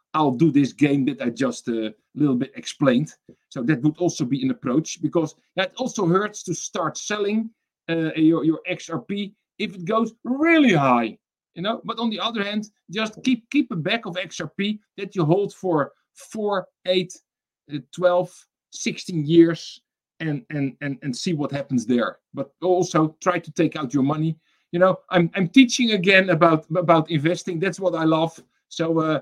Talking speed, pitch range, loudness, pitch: 185 wpm, 155-205 Hz, -22 LUFS, 175 Hz